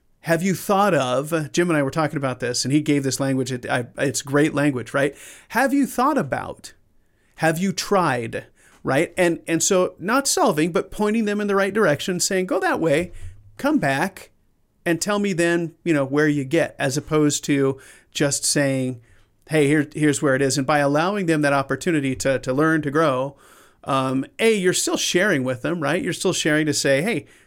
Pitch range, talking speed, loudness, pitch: 135-180 Hz, 200 wpm, -21 LUFS, 150 Hz